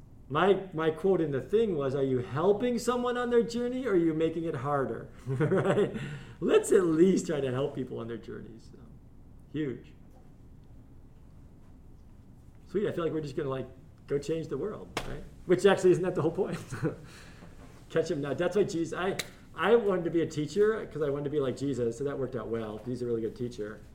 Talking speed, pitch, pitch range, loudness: 210 wpm, 155 Hz, 130-185 Hz, -30 LUFS